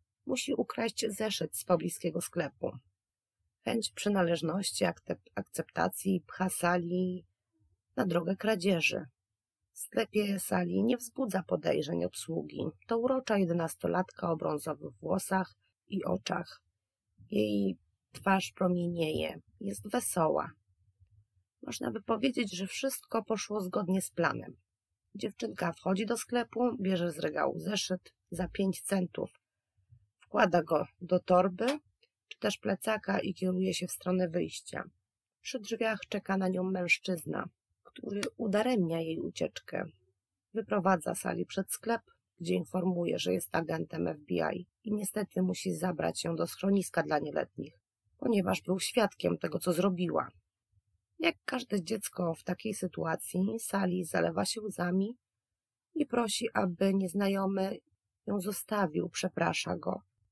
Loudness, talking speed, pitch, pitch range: -33 LUFS, 120 wpm, 185 Hz, 145-205 Hz